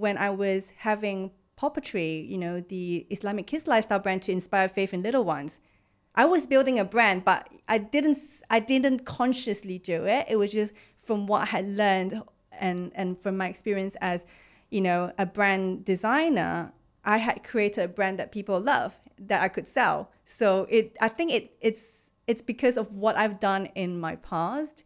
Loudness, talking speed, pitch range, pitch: -27 LUFS, 185 wpm, 190-225 Hz, 205 Hz